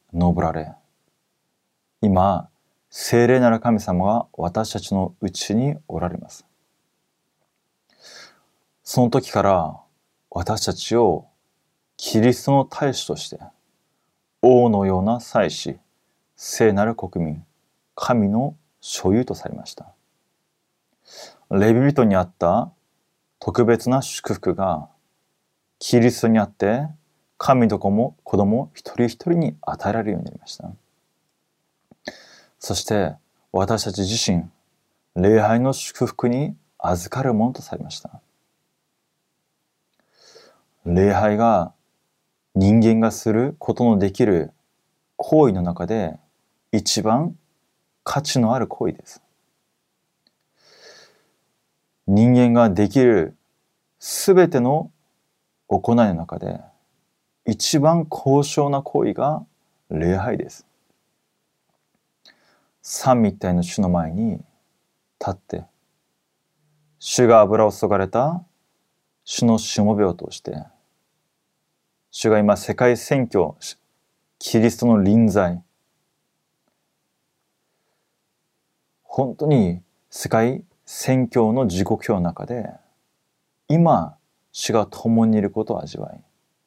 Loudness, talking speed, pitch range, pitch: -20 LUFS, 180 characters per minute, 100-125 Hz, 115 Hz